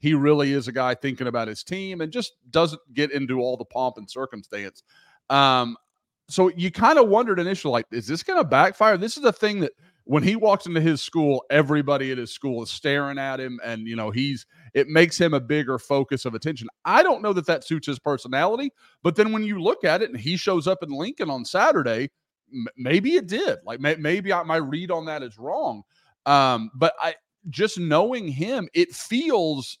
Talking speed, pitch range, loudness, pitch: 210 wpm, 130-180 Hz, -23 LUFS, 150 Hz